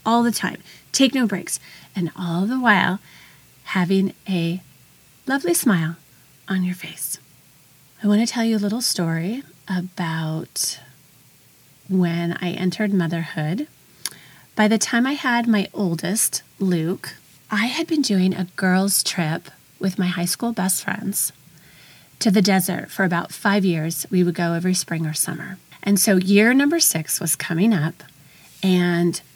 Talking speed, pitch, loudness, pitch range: 150 wpm, 185 Hz, -21 LUFS, 165-205 Hz